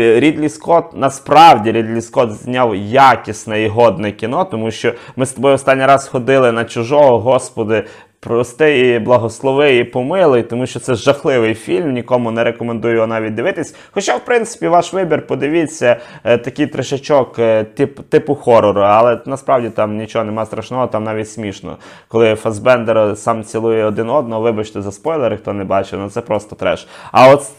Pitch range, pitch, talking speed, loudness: 110-135 Hz, 120 Hz, 165 wpm, -14 LUFS